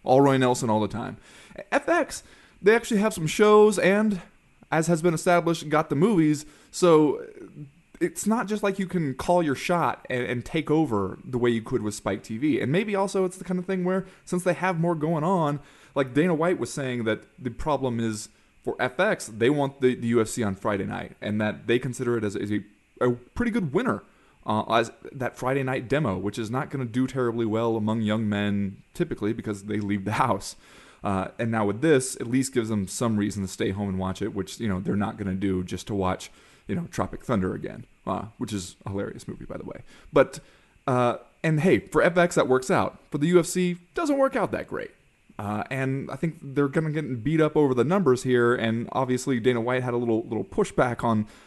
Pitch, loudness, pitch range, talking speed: 130 Hz, -25 LUFS, 110-170 Hz, 225 wpm